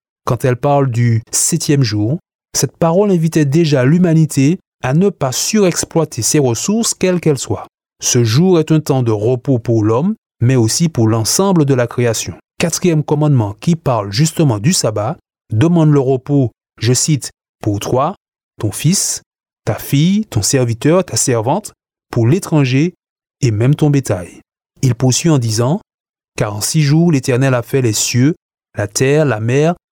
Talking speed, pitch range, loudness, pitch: 160 wpm, 120-160 Hz, -14 LUFS, 140 Hz